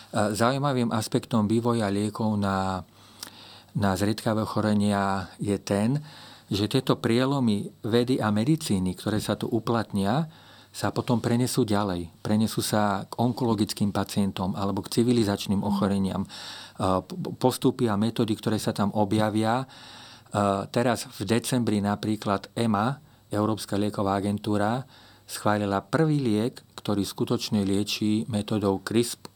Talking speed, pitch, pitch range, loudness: 115 wpm, 110 Hz, 100-120 Hz, -26 LUFS